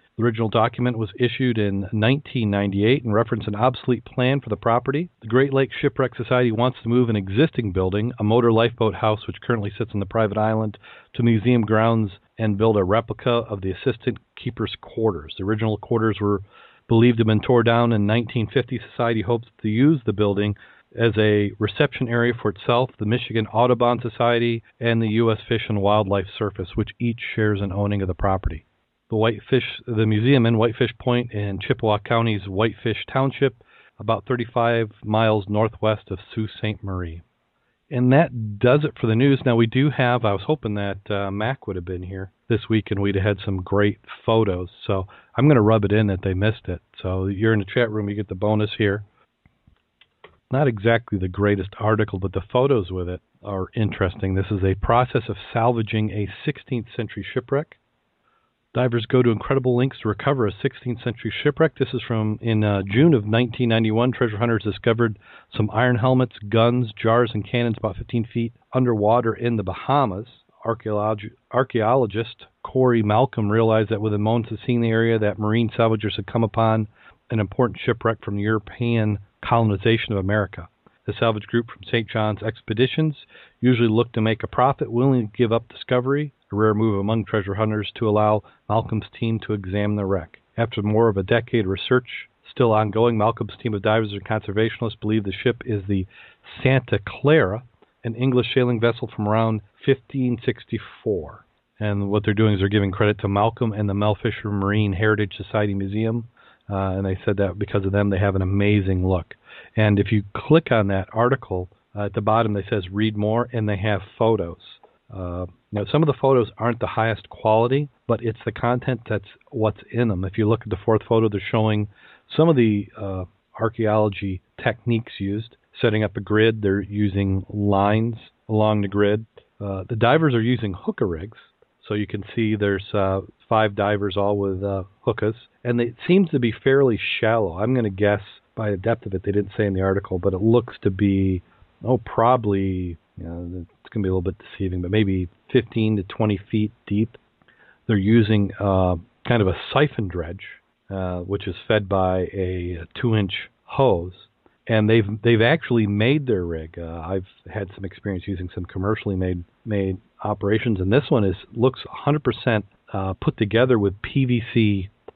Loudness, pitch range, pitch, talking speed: -22 LUFS, 100-120 Hz, 110 Hz, 185 wpm